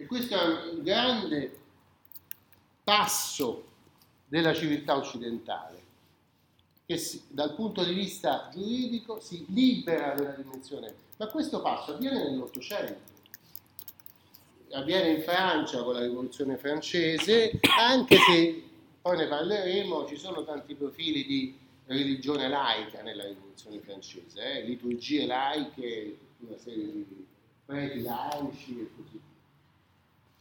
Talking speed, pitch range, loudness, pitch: 110 wpm, 130-185 Hz, -28 LUFS, 150 Hz